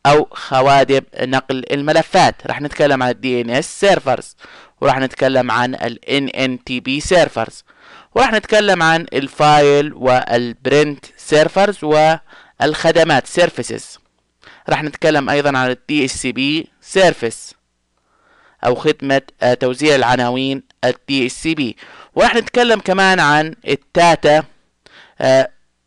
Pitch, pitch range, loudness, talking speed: 140 Hz, 125-160 Hz, -15 LUFS, 120 wpm